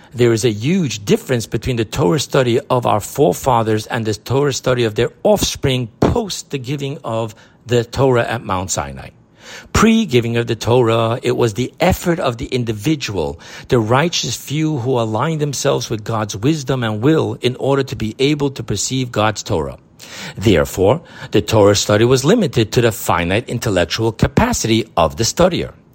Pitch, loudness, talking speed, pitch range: 120 Hz, -17 LUFS, 170 wpm, 110-135 Hz